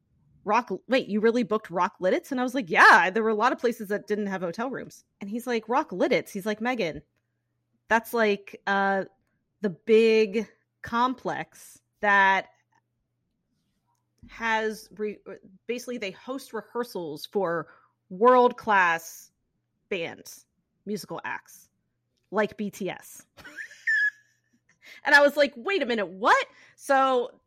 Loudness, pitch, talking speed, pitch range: -25 LUFS, 215 Hz, 130 wpm, 195-245 Hz